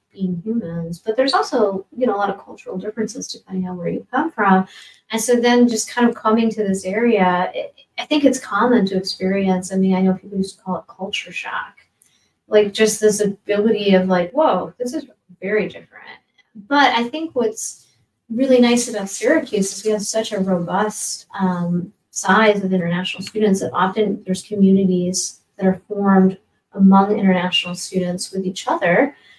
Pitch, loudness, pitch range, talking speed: 200 Hz, -18 LUFS, 185-225 Hz, 180 wpm